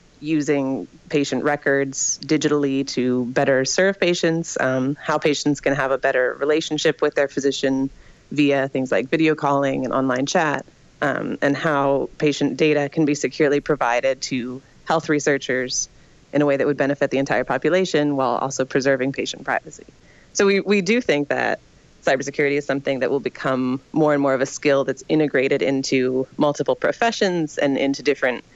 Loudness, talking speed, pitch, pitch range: -21 LUFS, 165 wpm, 140 Hz, 135-150 Hz